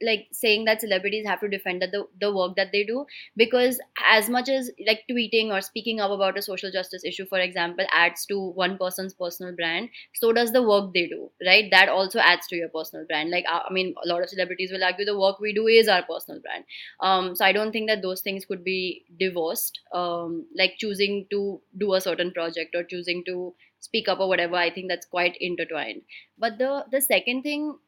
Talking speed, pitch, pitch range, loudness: 220 wpm, 190 Hz, 180-215 Hz, -24 LUFS